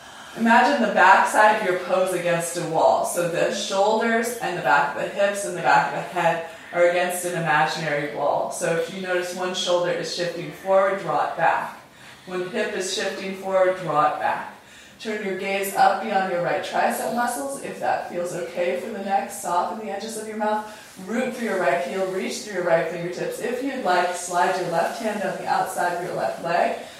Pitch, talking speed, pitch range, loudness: 185 Hz, 215 wpm, 175-200 Hz, -23 LUFS